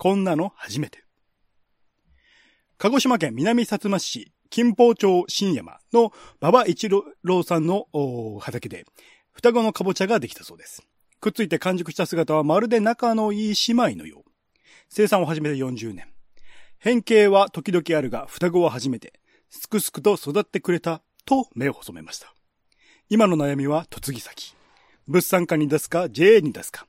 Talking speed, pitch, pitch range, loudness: 290 characters per minute, 185 Hz, 155-215 Hz, -21 LUFS